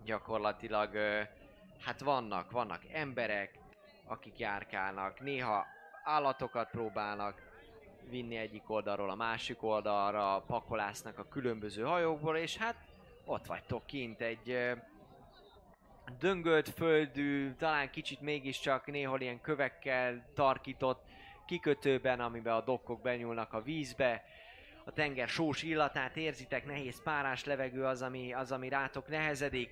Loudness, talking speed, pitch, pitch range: -37 LUFS, 115 wpm, 130 Hz, 115-145 Hz